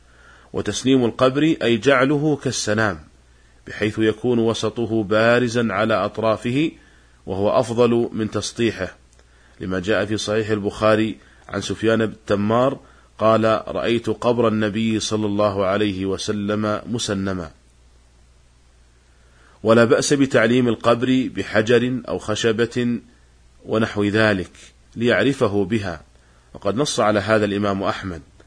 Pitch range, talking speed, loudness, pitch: 90-115 Hz, 105 wpm, -20 LUFS, 105 Hz